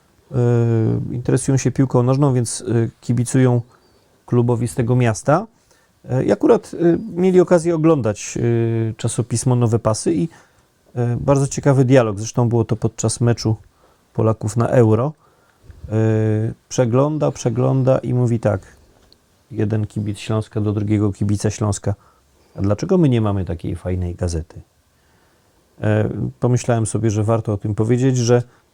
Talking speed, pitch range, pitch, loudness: 120 wpm, 105-125 Hz, 115 Hz, -18 LUFS